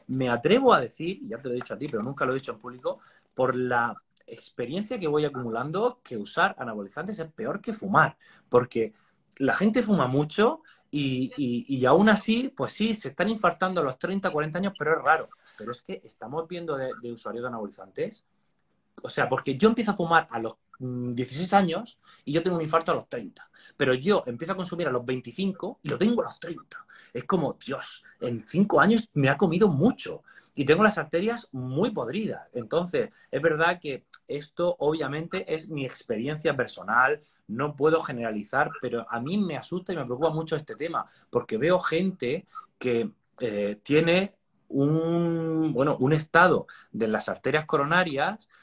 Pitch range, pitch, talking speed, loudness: 130-195 Hz, 160 Hz, 185 wpm, -26 LUFS